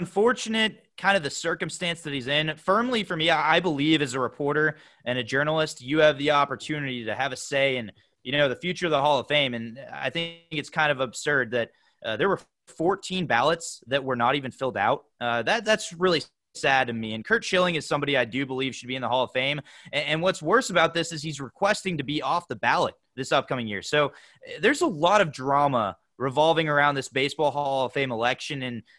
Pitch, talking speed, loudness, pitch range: 145 Hz, 230 wpm, -25 LUFS, 130-170 Hz